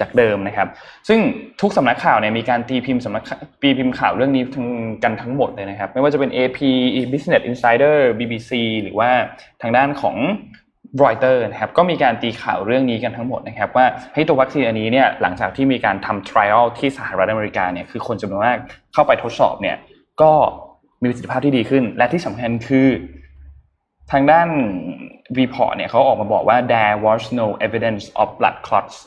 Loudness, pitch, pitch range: -17 LUFS, 125 Hz, 110-140 Hz